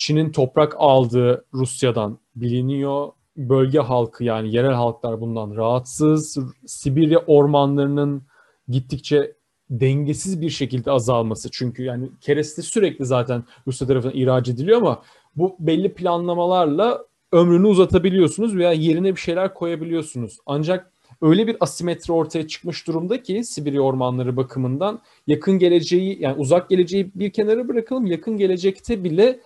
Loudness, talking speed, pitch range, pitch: -20 LUFS, 125 wpm, 130-180 Hz, 150 Hz